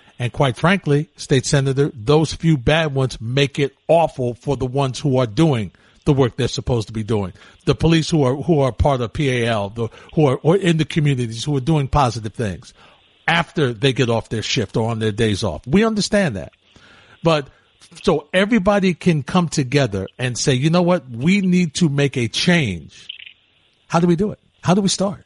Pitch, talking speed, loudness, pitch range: 140 Hz, 200 wpm, -19 LUFS, 120-165 Hz